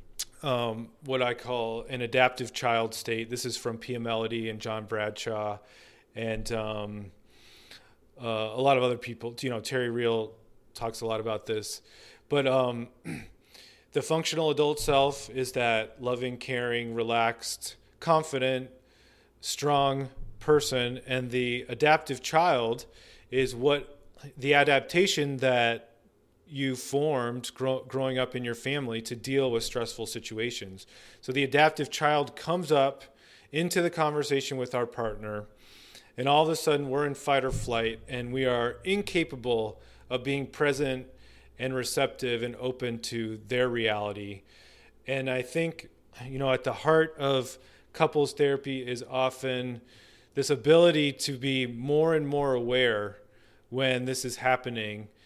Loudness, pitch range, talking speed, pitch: -28 LUFS, 115-140 Hz, 140 wpm, 125 Hz